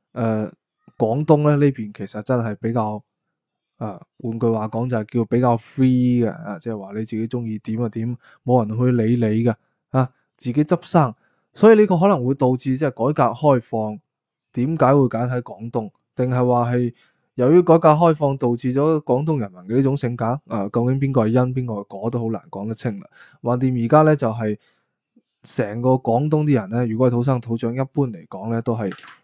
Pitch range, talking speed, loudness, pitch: 115-135 Hz, 300 characters per minute, -20 LUFS, 120 Hz